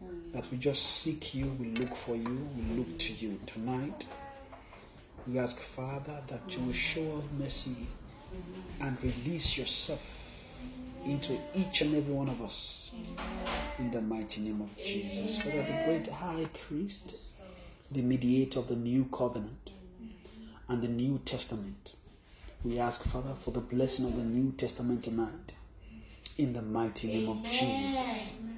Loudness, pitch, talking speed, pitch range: -34 LUFS, 125 Hz, 150 wpm, 115-150 Hz